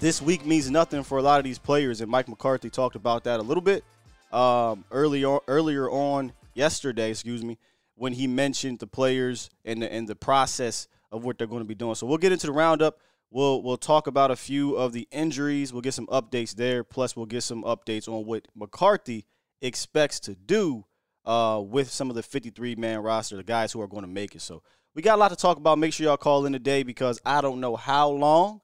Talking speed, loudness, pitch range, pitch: 230 wpm, -25 LUFS, 115-140 Hz, 125 Hz